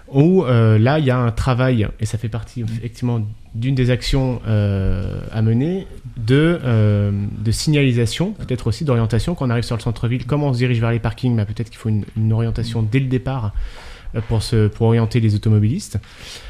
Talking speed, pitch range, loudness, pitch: 200 wpm, 110-125 Hz, -19 LUFS, 115 Hz